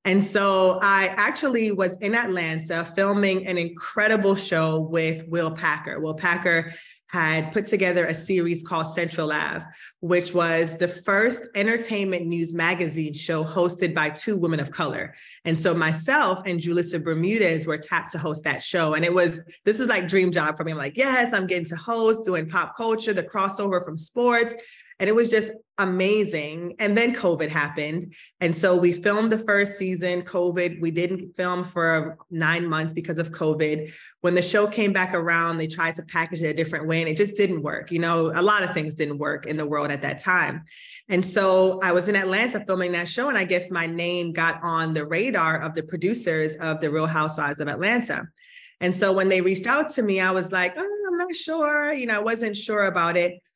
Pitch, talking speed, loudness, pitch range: 175 Hz, 205 wpm, -23 LUFS, 165-200 Hz